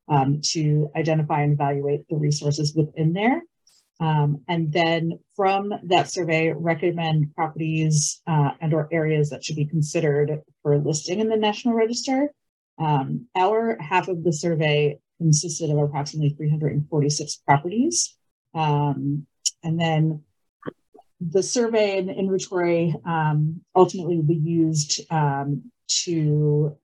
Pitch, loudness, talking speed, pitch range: 160 Hz, -23 LUFS, 125 wpm, 150-175 Hz